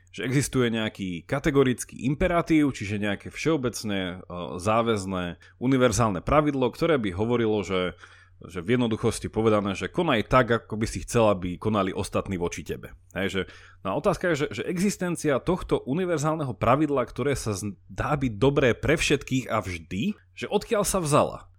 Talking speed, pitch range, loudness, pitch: 145 wpm, 95-140 Hz, -26 LUFS, 110 Hz